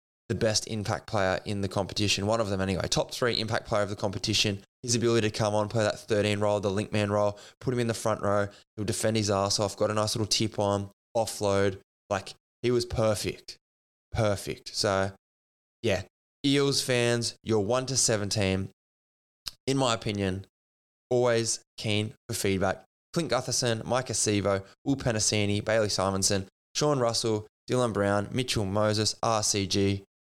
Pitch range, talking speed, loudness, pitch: 100-115 Hz, 165 wpm, -28 LUFS, 105 Hz